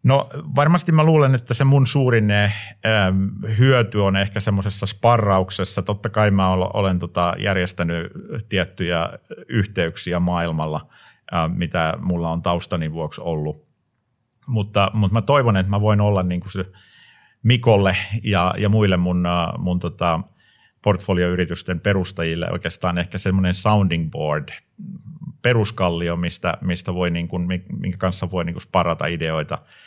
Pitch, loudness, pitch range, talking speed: 95 Hz, -20 LUFS, 90-110 Hz, 130 wpm